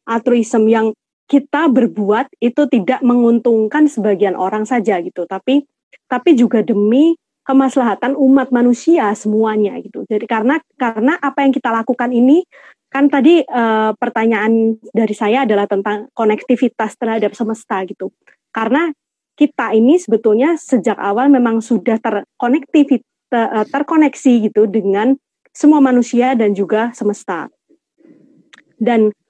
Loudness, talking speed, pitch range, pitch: -14 LUFS, 120 wpm, 220-275 Hz, 240 Hz